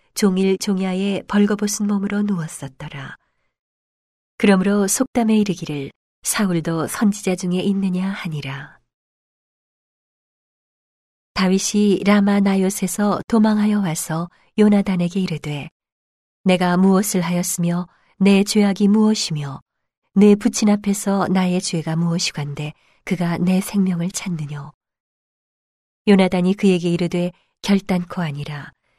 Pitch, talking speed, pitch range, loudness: 185 Hz, 255 characters per minute, 170-200 Hz, -19 LUFS